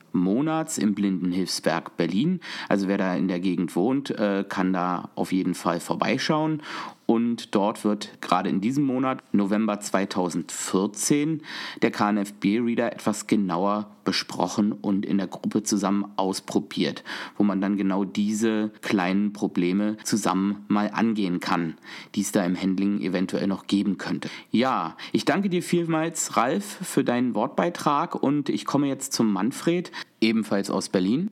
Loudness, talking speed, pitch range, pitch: -25 LUFS, 145 wpm, 95-115 Hz, 105 Hz